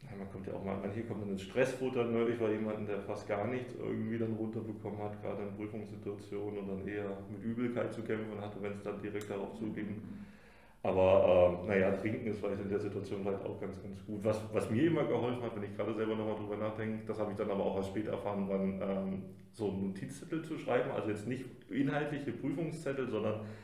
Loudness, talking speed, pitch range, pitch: -36 LUFS, 235 wpm, 100-110 Hz, 105 Hz